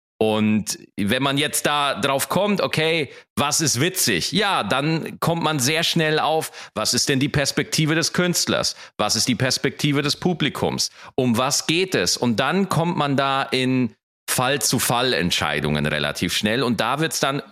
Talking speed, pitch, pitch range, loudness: 170 wpm, 140 Hz, 120-160 Hz, -20 LUFS